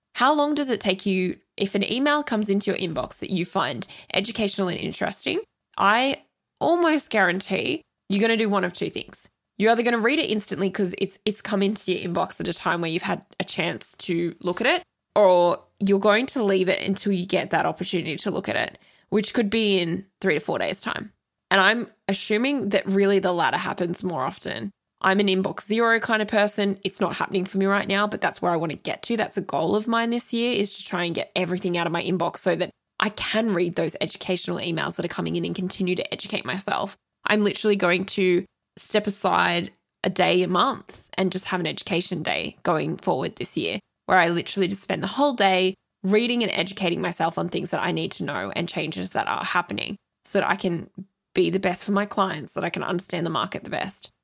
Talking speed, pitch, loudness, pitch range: 230 wpm, 195 Hz, -24 LUFS, 180-210 Hz